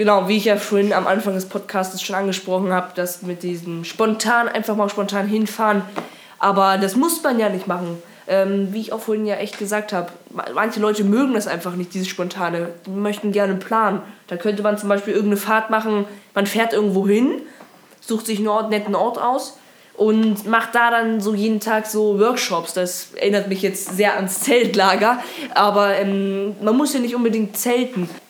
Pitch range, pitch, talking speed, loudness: 195-220 Hz, 205 Hz, 190 wpm, -19 LUFS